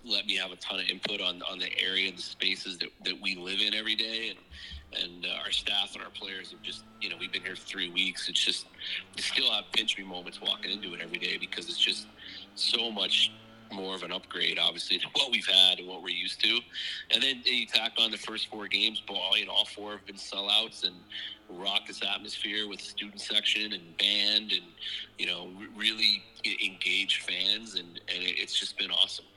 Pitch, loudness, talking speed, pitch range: 100 Hz, -28 LUFS, 220 wpm, 95-110 Hz